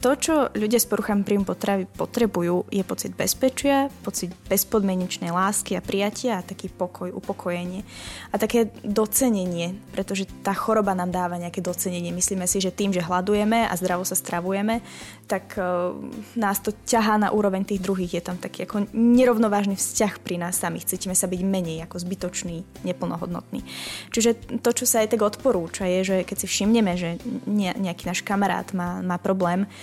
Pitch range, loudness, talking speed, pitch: 180-215 Hz, -24 LUFS, 170 wpm, 195 Hz